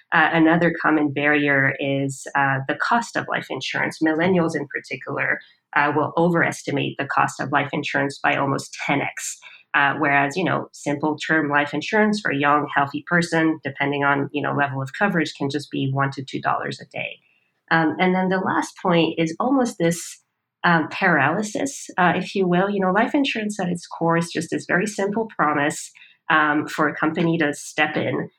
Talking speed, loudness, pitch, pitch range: 185 wpm, -21 LUFS, 155 Hz, 145-180 Hz